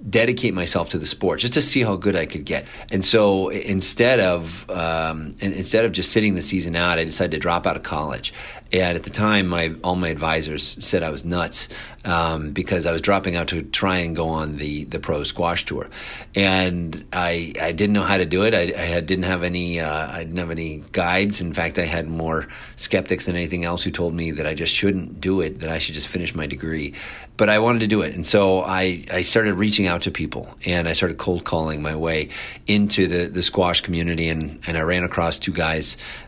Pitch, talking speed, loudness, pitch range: 90 Hz, 235 wpm, -20 LUFS, 80-95 Hz